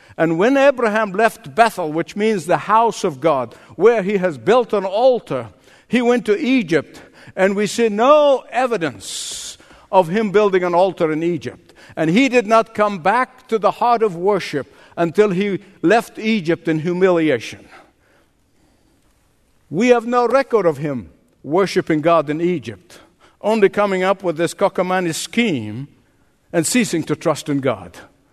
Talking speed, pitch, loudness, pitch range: 155 wpm, 190 Hz, -17 LUFS, 165-225 Hz